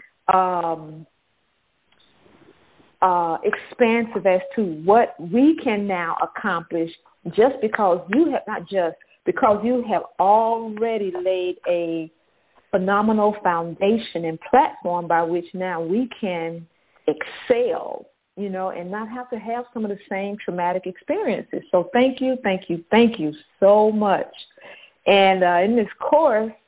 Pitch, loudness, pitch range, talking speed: 195 Hz, -21 LUFS, 175-225 Hz, 135 wpm